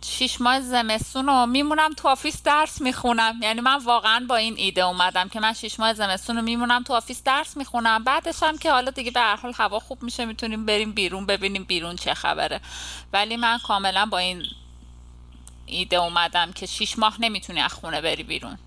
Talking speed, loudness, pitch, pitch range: 190 wpm, -22 LUFS, 225 Hz, 190-250 Hz